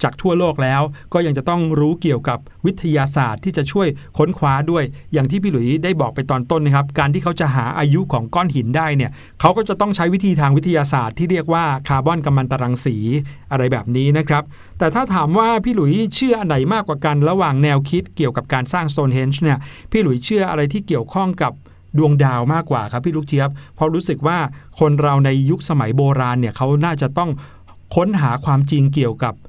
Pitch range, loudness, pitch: 135-170 Hz, -17 LUFS, 150 Hz